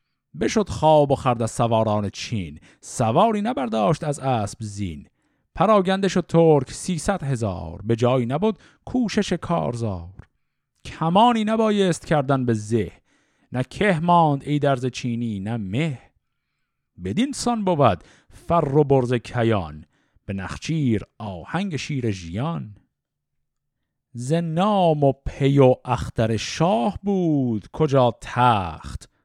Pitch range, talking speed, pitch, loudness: 110-170 Hz, 115 wpm, 135 Hz, -22 LUFS